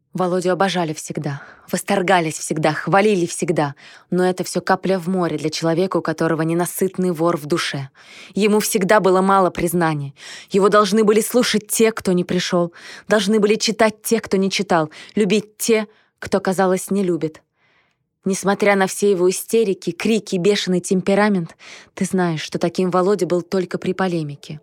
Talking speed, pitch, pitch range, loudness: 155 wpm, 185 Hz, 175-205 Hz, -19 LUFS